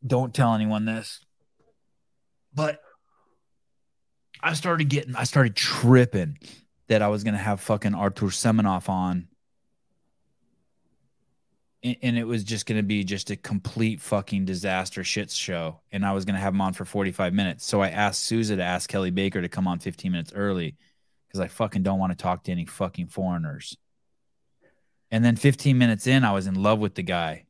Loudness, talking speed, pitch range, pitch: -25 LUFS, 180 wpm, 95-115 Hz, 105 Hz